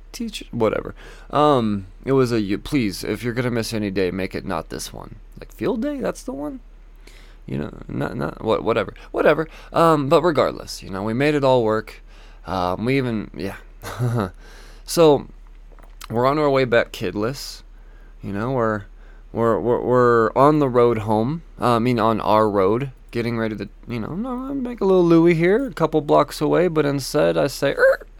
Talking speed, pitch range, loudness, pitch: 185 wpm, 110-155 Hz, -20 LUFS, 125 Hz